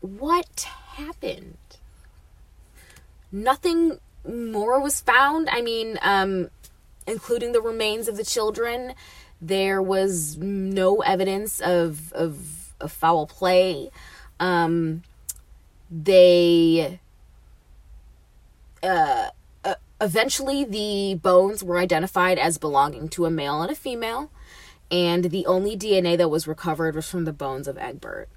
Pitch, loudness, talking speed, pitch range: 180 Hz, -22 LUFS, 115 wpm, 155-220 Hz